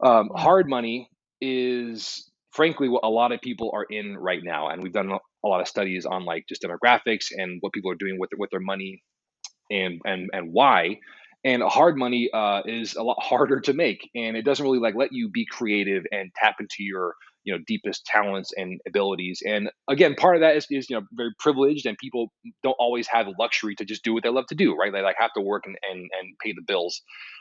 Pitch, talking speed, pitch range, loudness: 115 Hz, 240 wpm, 100-125 Hz, -24 LUFS